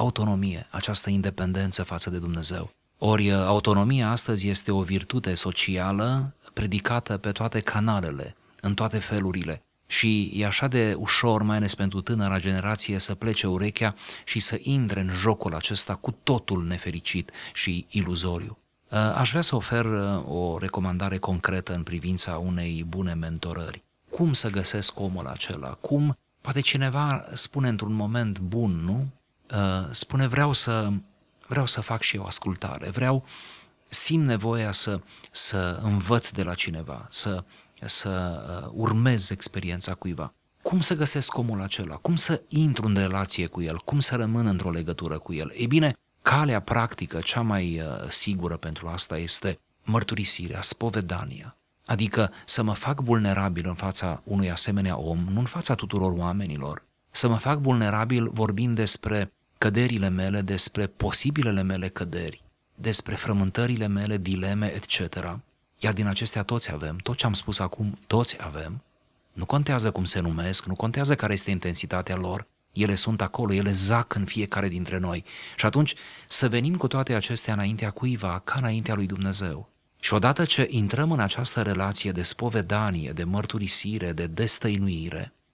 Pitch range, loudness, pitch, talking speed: 95-115 Hz, -22 LUFS, 100 Hz, 150 wpm